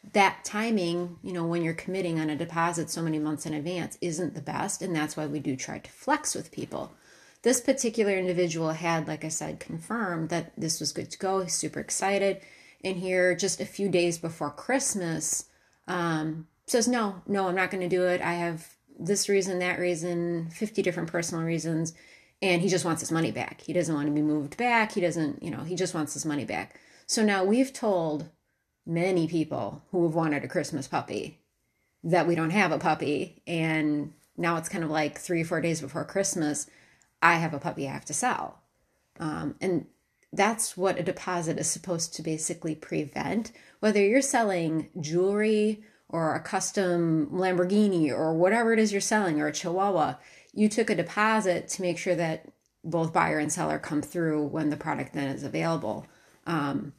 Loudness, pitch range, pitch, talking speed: -28 LUFS, 160-190 Hz, 170 Hz, 195 wpm